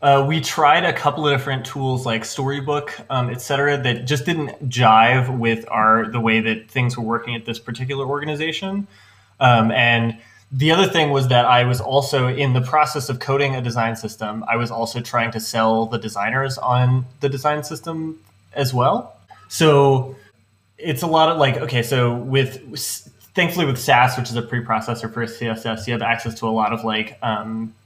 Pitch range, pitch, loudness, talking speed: 115-140 Hz, 125 Hz, -19 LUFS, 190 wpm